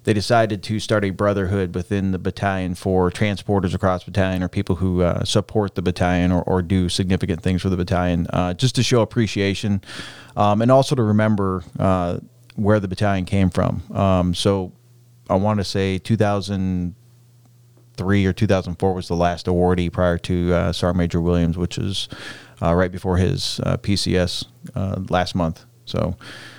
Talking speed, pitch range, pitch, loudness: 170 wpm, 90-105 Hz, 95 Hz, -20 LUFS